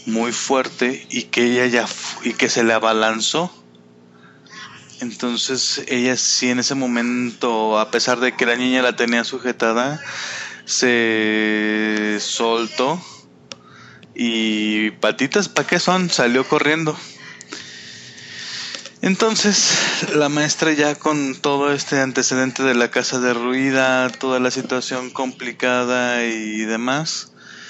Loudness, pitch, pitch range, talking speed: -18 LUFS, 125 Hz, 110-130 Hz, 120 wpm